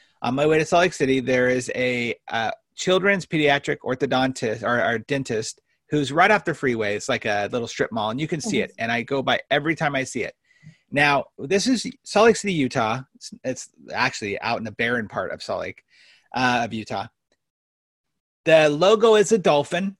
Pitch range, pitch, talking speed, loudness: 125-180 Hz, 140 Hz, 205 wpm, -22 LUFS